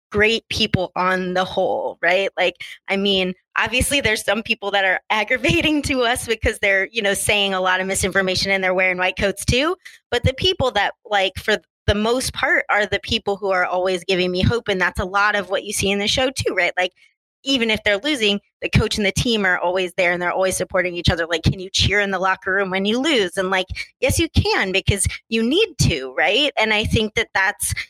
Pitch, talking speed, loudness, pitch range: 200 Hz, 235 wpm, -19 LUFS, 185-225 Hz